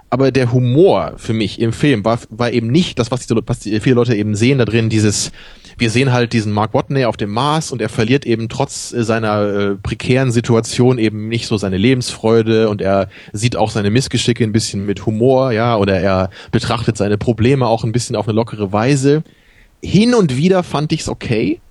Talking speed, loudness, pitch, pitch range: 205 wpm, -15 LUFS, 115 Hz, 110-130 Hz